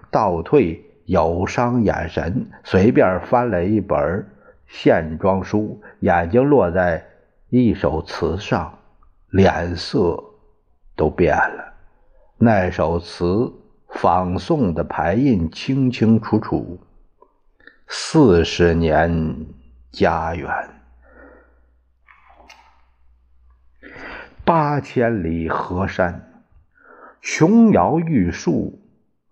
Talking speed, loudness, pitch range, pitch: 110 characters per minute, -18 LUFS, 80-105 Hz, 90 Hz